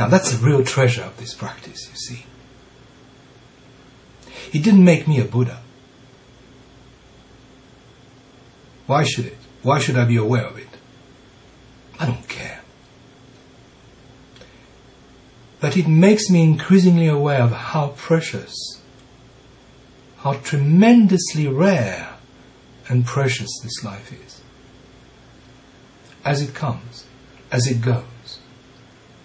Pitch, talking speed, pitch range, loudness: 130 Hz, 105 wpm, 125-140 Hz, -18 LUFS